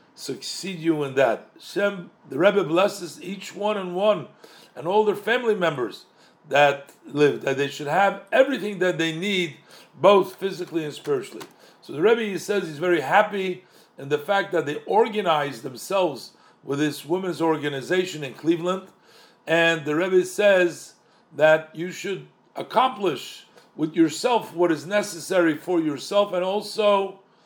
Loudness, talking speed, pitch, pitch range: -23 LUFS, 150 wpm, 180 Hz, 160-200 Hz